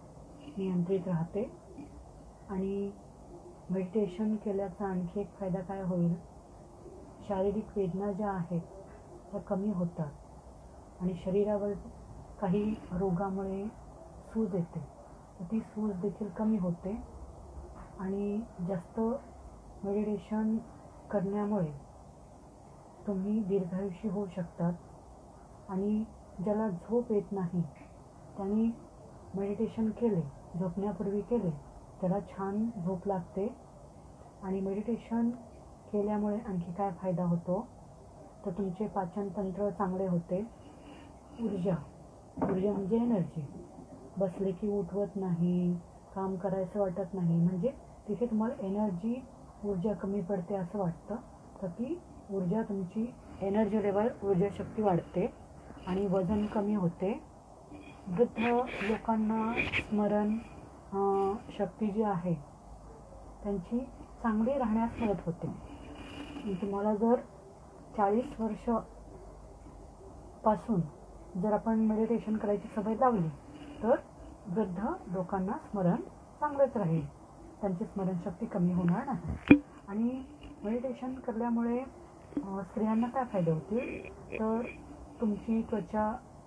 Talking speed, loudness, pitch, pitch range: 95 wpm, -34 LUFS, 200 Hz, 185-220 Hz